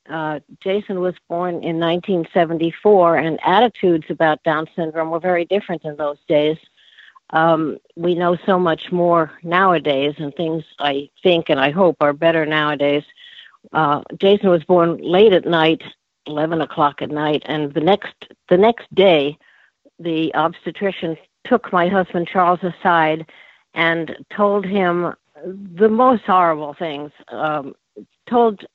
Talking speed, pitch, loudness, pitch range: 140 wpm, 170 Hz, -18 LUFS, 155-185 Hz